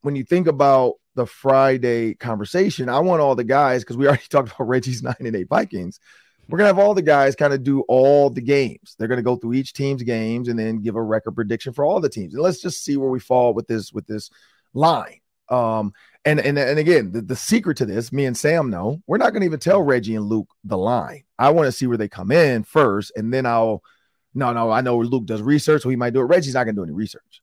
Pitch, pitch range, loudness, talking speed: 130 Hz, 115-145 Hz, -19 LUFS, 255 wpm